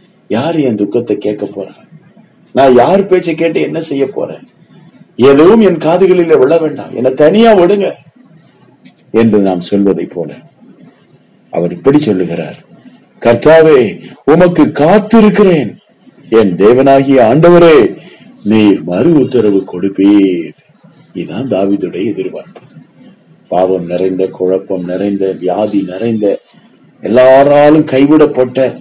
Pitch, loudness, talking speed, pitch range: 130 Hz, -9 LUFS, 95 wpm, 100-160 Hz